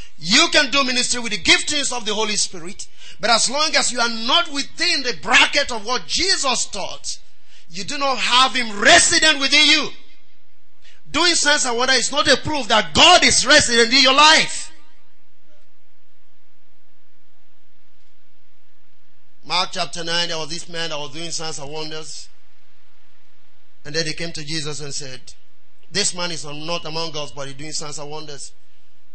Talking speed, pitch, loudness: 165 wpm, 220 Hz, -16 LUFS